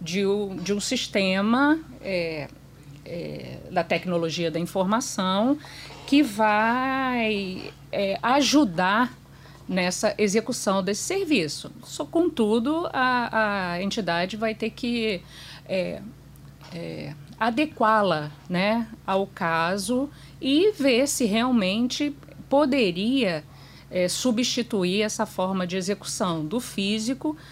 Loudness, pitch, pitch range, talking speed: -24 LUFS, 215 Hz, 185-250 Hz, 100 wpm